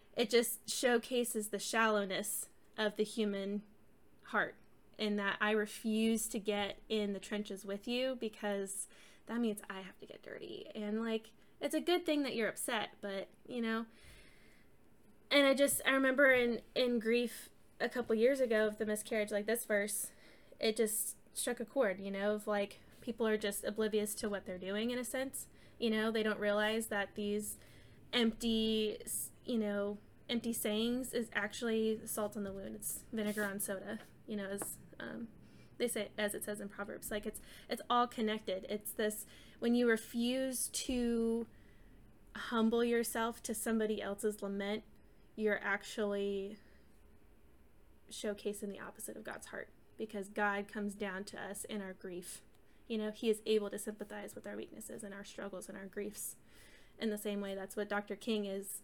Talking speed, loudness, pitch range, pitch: 175 wpm, -37 LUFS, 205-230 Hz, 215 Hz